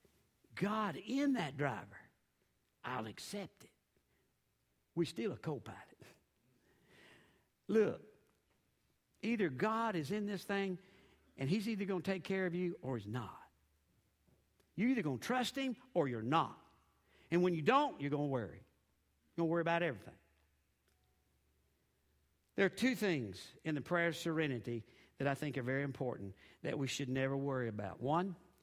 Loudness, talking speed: -38 LUFS, 155 wpm